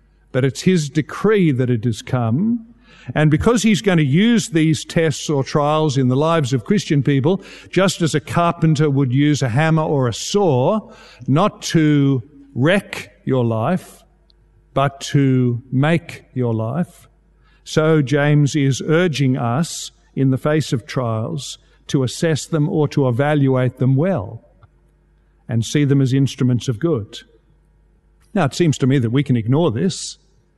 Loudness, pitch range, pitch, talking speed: -18 LUFS, 130-165 Hz, 145 Hz, 155 wpm